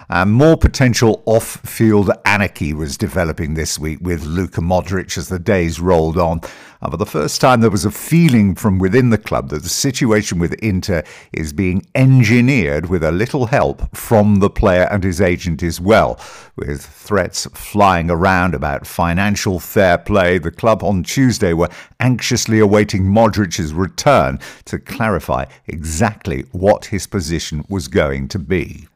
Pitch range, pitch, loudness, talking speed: 85-110 Hz, 95 Hz, -15 LUFS, 160 wpm